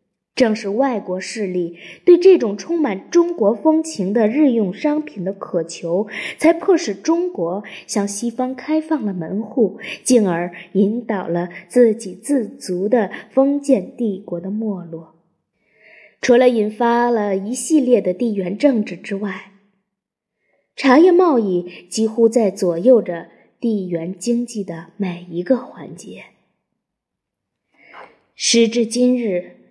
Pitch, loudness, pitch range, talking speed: 215 Hz, -18 LUFS, 190-250 Hz, 185 characters per minute